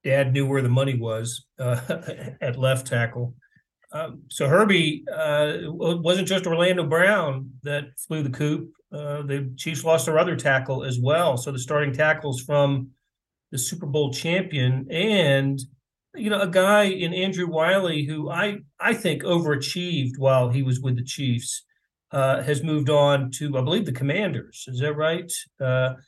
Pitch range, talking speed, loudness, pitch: 135-170 Hz, 170 wpm, -23 LUFS, 145 Hz